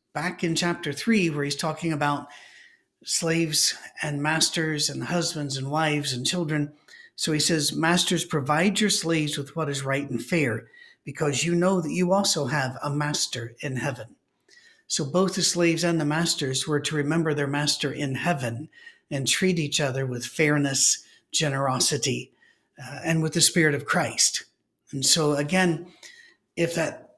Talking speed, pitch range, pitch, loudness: 165 wpm, 145-175 Hz, 155 Hz, -24 LUFS